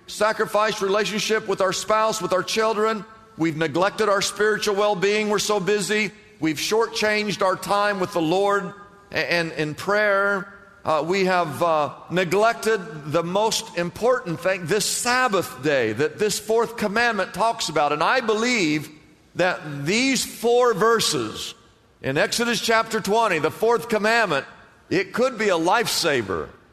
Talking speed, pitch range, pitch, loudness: 145 wpm, 180-220 Hz, 205 Hz, -22 LUFS